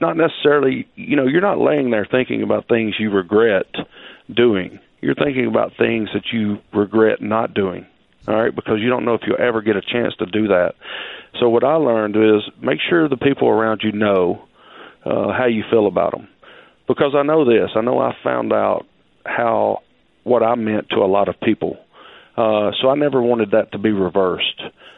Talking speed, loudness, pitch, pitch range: 200 wpm, -18 LUFS, 110 Hz, 105-130 Hz